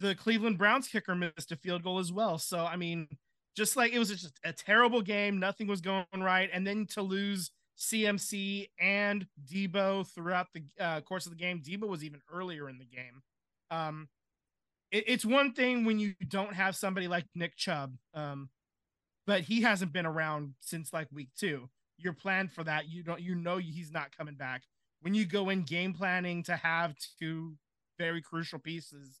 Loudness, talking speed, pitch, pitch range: -33 LUFS, 190 wpm, 175 Hz, 160-200 Hz